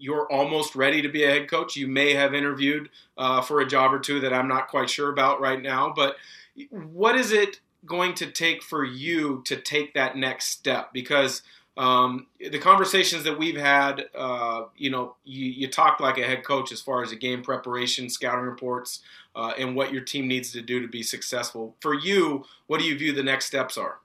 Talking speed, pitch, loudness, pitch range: 215 wpm, 135 Hz, -24 LUFS, 130-150 Hz